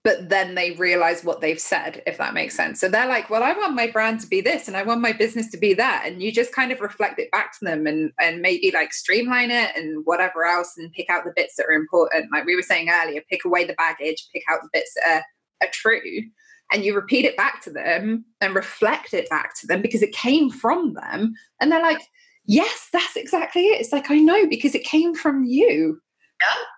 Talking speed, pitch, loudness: 240 wpm, 225 Hz, -21 LUFS